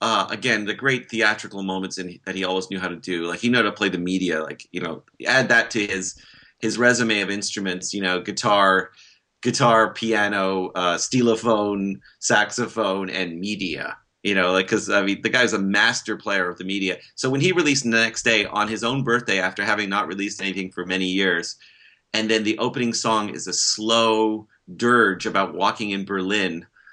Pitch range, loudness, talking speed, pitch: 95-115 Hz, -21 LUFS, 195 wpm, 100 Hz